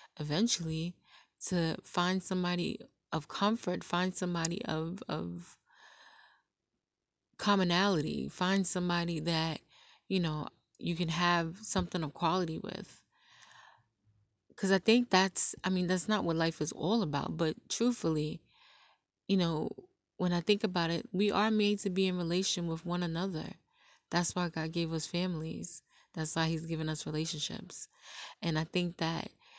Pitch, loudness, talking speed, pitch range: 175 Hz, -33 LUFS, 145 wpm, 160-195 Hz